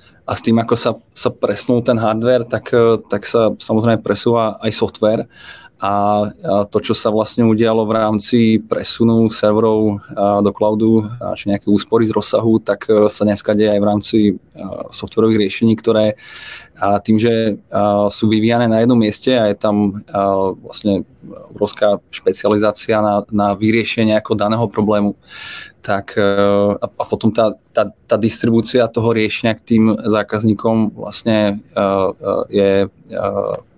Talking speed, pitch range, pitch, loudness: 135 wpm, 105-115 Hz, 110 Hz, -15 LUFS